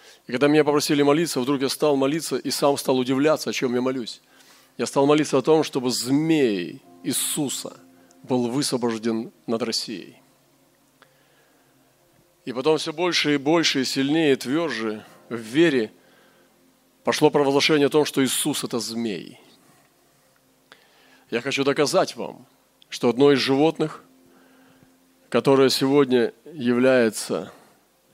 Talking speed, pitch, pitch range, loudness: 130 wpm, 135 Hz, 120-150 Hz, -22 LUFS